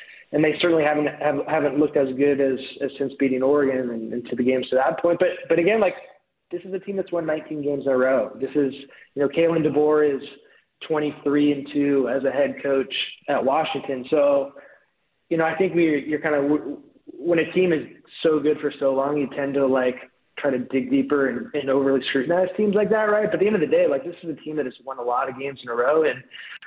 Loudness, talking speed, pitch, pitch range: -22 LUFS, 245 wpm, 145 Hz, 135-165 Hz